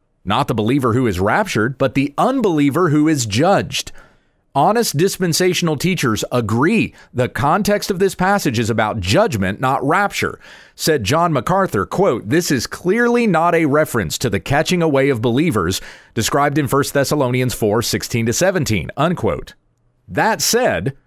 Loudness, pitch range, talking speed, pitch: -17 LUFS, 120-170 Hz, 140 wpm, 140 Hz